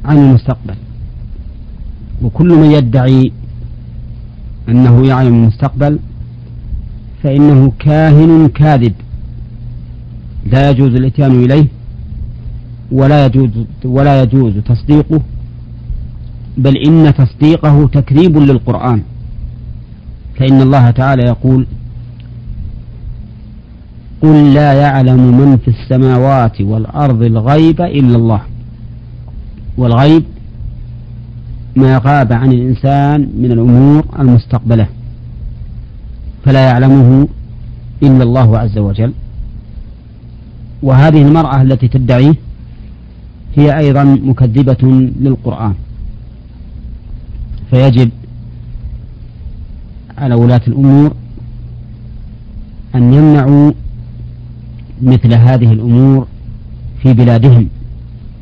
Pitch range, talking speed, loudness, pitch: 115-135 Hz, 75 wpm, -8 LUFS, 125 Hz